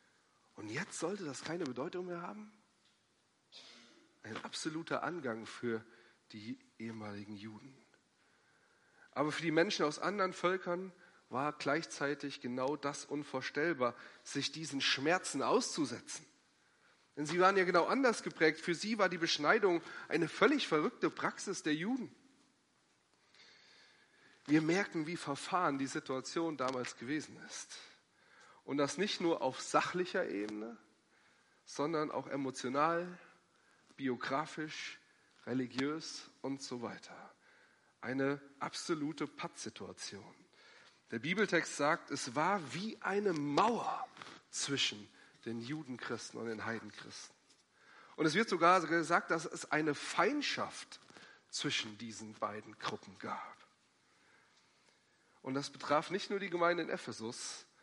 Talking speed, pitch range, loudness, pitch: 115 wpm, 130-180 Hz, -37 LUFS, 150 Hz